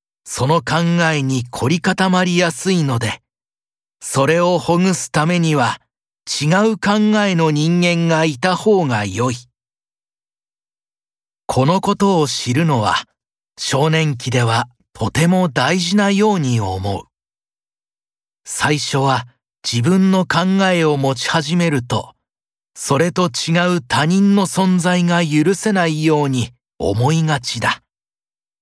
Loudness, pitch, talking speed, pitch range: -16 LUFS, 160 Hz, 215 characters per minute, 130-180 Hz